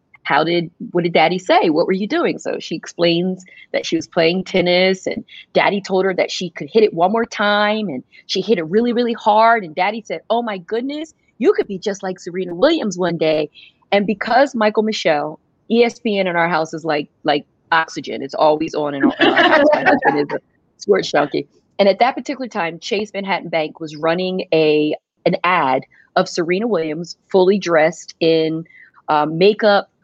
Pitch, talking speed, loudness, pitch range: 185 Hz, 195 wpm, -17 LUFS, 165-220 Hz